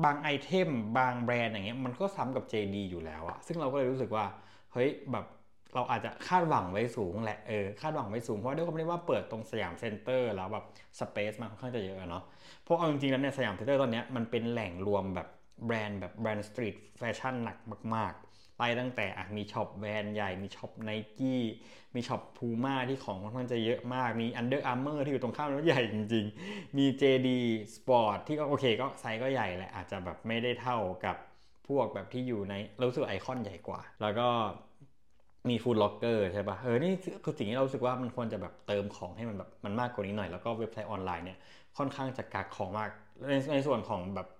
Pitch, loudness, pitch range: 115 Hz, -34 LUFS, 105-130 Hz